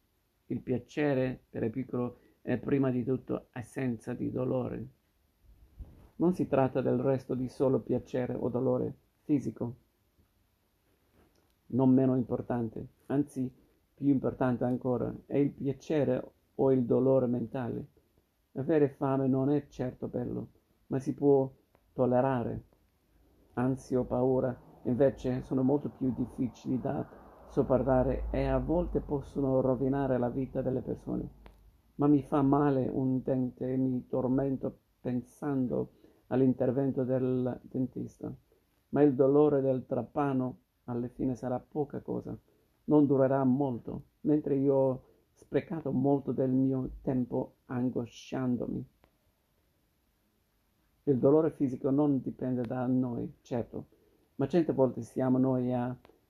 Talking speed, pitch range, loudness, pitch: 125 wpm, 120-135 Hz, -31 LUFS, 130 Hz